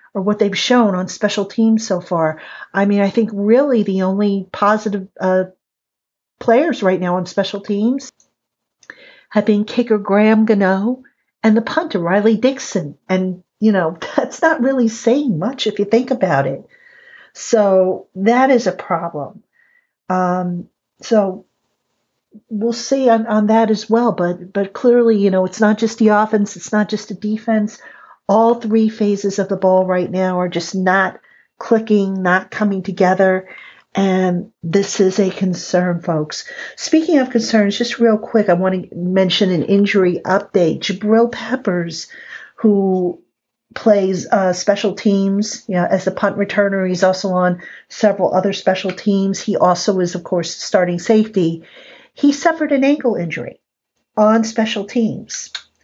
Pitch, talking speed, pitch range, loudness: 205 Hz, 155 wpm, 185-225 Hz, -16 LUFS